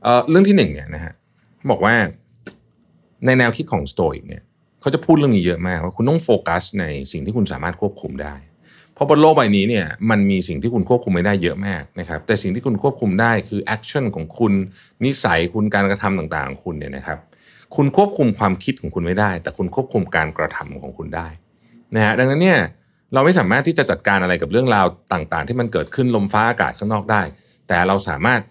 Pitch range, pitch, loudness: 90-120 Hz, 105 Hz, -18 LUFS